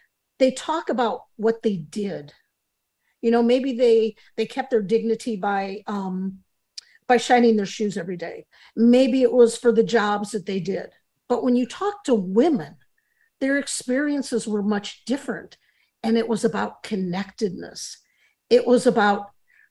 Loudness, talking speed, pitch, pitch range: -22 LUFS, 150 wpm, 230 Hz, 210-250 Hz